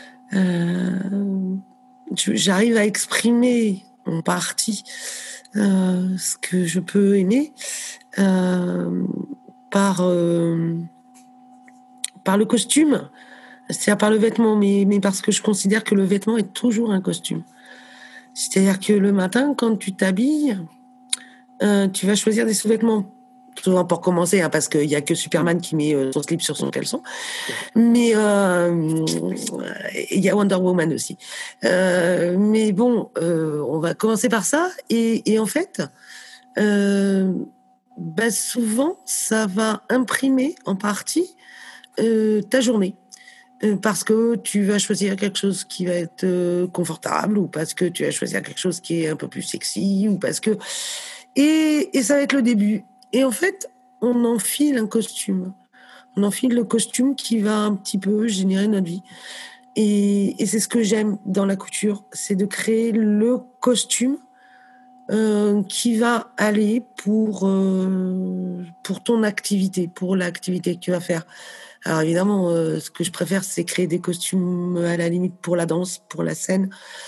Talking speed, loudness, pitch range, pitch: 155 wpm, -21 LUFS, 185-240 Hz, 205 Hz